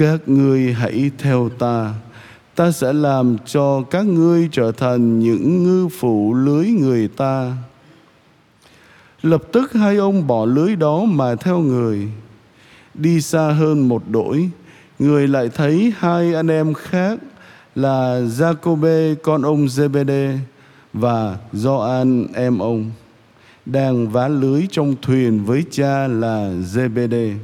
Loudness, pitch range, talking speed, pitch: -17 LUFS, 120-160 Hz, 130 wpm, 135 Hz